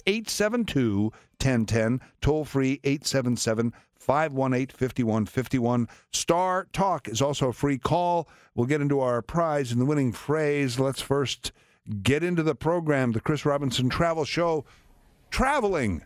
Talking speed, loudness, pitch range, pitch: 130 wpm, -26 LUFS, 120-155 Hz, 135 Hz